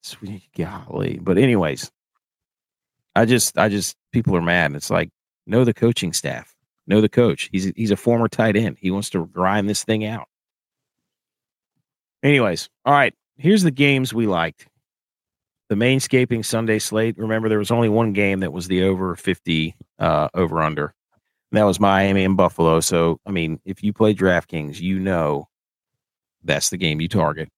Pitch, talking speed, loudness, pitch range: 100 Hz, 170 wpm, -20 LUFS, 90-115 Hz